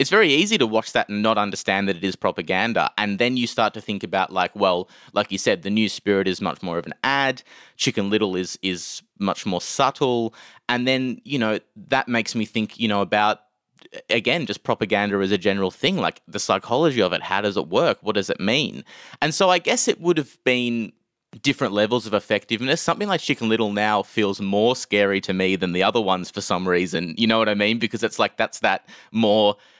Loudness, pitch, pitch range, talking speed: -22 LUFS, 105 Hz, 100-125 Hz, 225 wpm